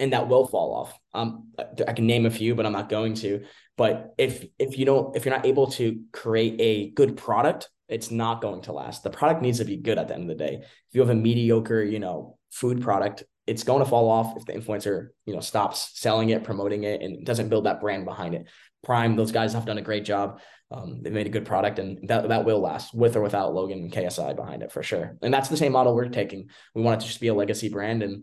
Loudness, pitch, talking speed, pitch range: -25 LUFS, 115 Hz, 265 wpm, 105-120 Hz